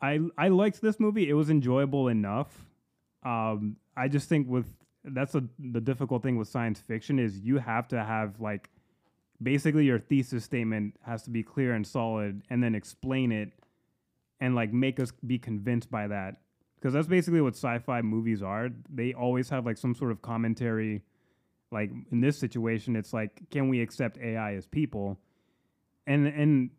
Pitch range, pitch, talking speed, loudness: 110-135 Hz, 120 Hz, 175 wpm, -30 LUFS